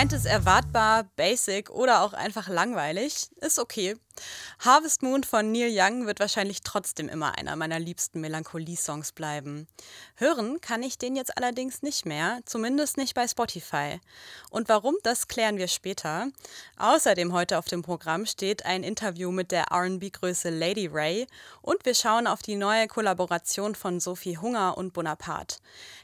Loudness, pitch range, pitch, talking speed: -27 LUFS, 175-235 Hz, 200 Hz, 155 wpm